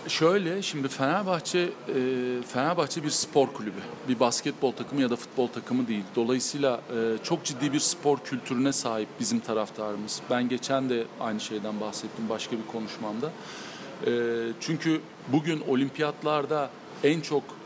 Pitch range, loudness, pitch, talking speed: 115-150 Hz, -28 LUFS, 130 Hz, 130 wpm